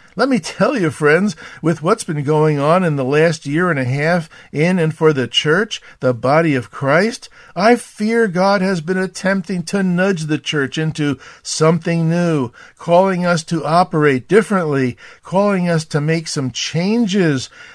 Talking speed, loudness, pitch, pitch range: 170 wpm, -16 LUFS, 165 Hz, 150-190 Hz